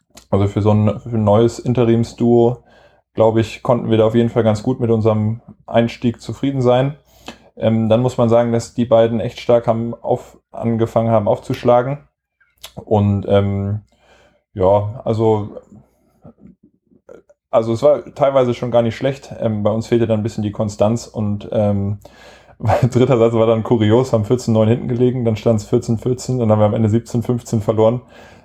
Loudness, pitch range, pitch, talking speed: -17 LUFS, 110-120 Hz, 115 Hz, 175 wpm